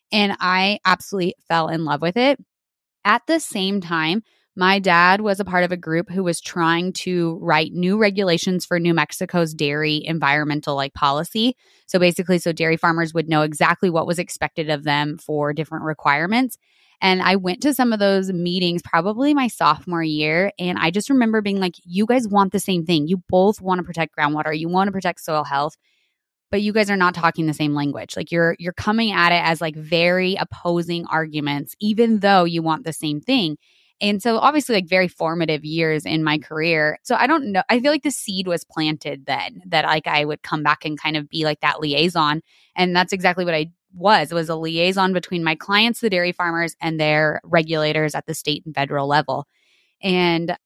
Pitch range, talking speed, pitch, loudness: 155-195 Hz, 205 wpm, 170 Hz, -20 LUFS